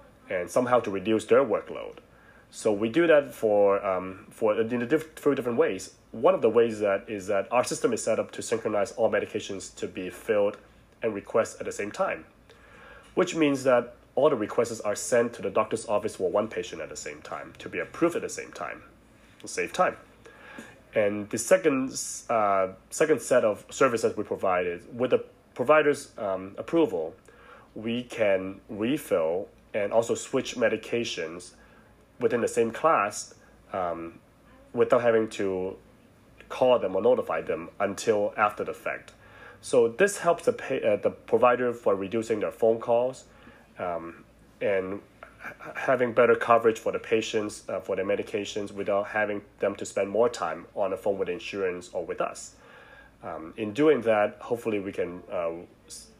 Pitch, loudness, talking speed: 125 Hz, -27 LUFS, 170 wpm